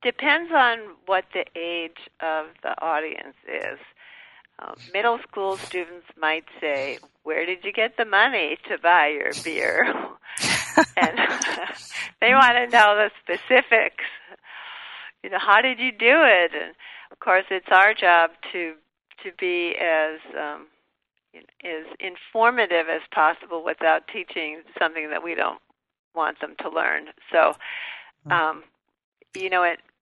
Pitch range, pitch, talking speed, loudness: 165-235 Hz, 190 Hz, 140 wpm, -21 LUFS